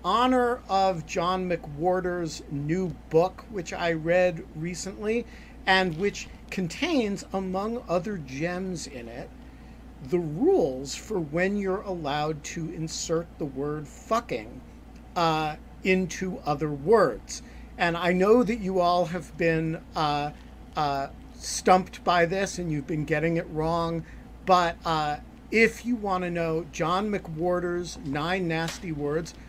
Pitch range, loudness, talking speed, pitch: 160-190 Hz, -27 LUFS, 130 wpm, 175 Hz